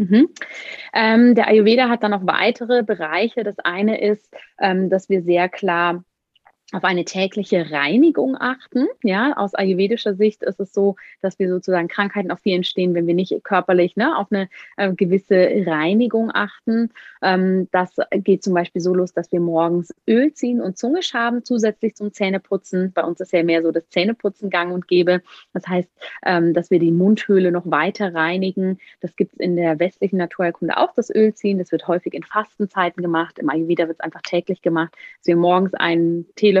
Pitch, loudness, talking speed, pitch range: 190 Hz, -19 LUFS, 190 wpm, 175-210 Hz